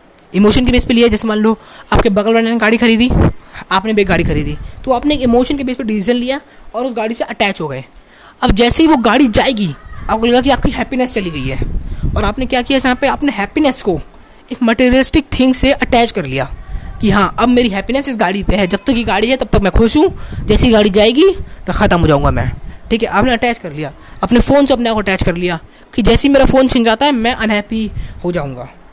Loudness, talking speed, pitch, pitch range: -12 LUFS, 245 wpm, 230 Hz, 195-255 Hz